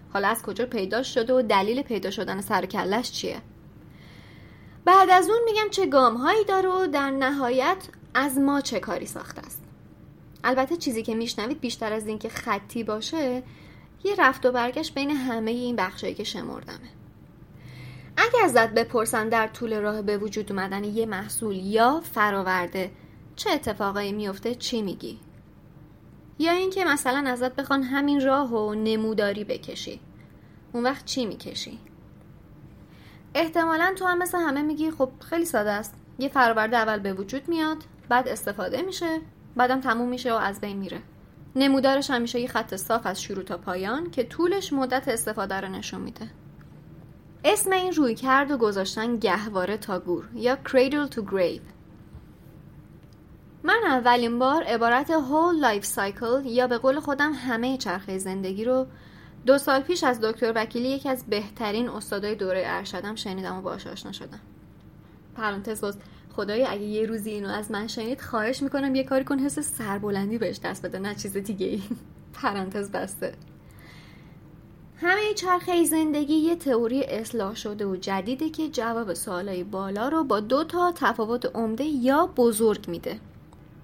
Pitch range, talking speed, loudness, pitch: 210-275 Hz, 155 wpm, -25 LUFS, 240 Hz